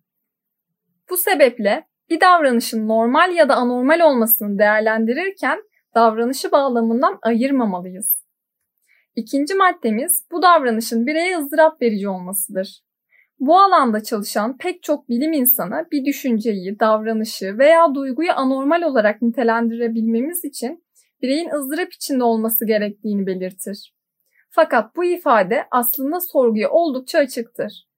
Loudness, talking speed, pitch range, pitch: -18 LUFS, 105 wpm, 220-315 Hz, 245 Hz